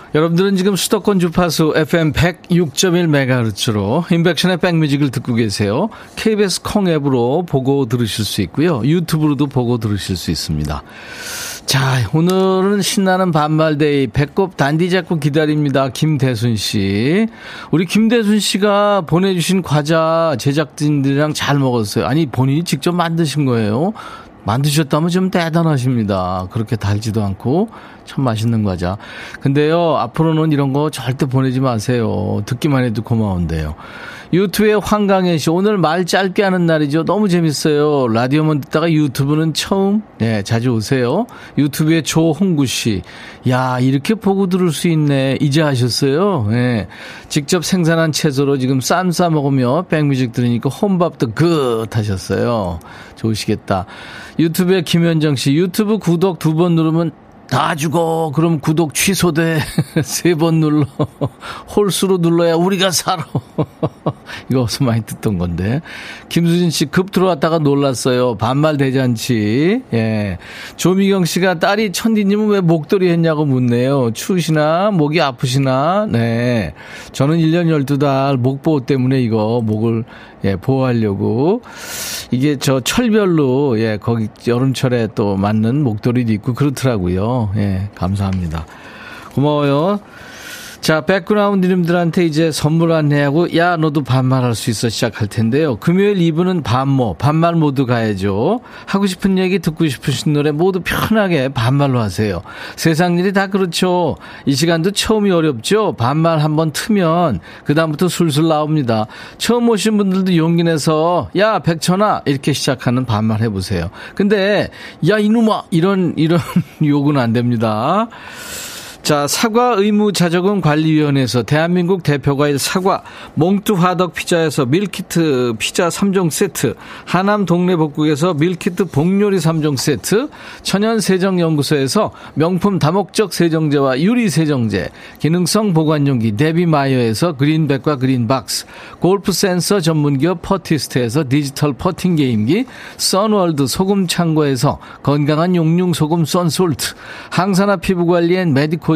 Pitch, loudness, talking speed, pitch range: 155 Hz, -15 LUFS, 305 characters per minute, 130-180 Hz